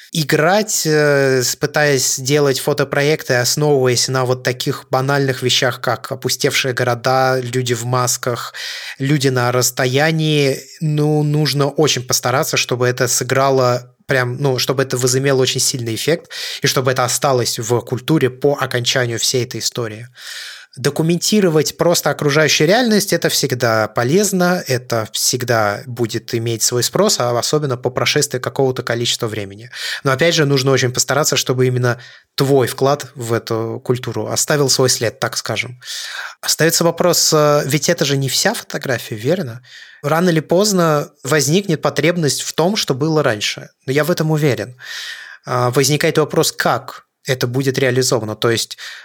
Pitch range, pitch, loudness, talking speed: 125-150 Hz, 135 Hz, -16 LUFS, 140 wpm